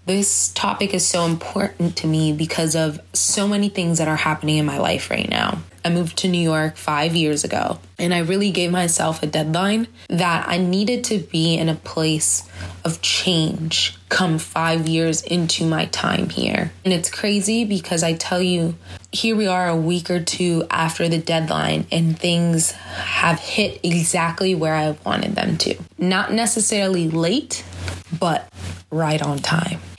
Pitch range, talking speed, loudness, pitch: 155-180 Hz, 170 wpm, -20 LUFS, 165 Hz